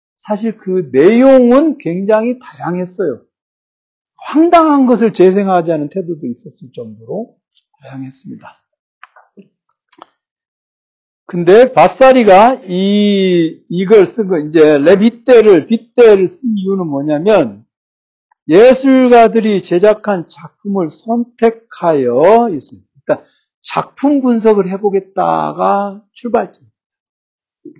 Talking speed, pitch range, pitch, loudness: 220 characters per minute, 165-235 Hz, 200 Hz, -11 LUFS